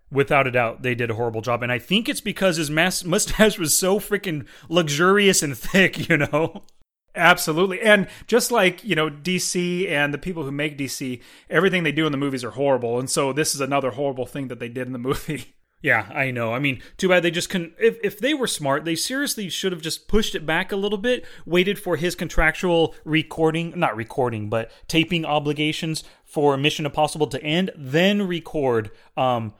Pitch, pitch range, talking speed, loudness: 160 Hz, 140-185 Hz, 205 wpm, -21 LUFS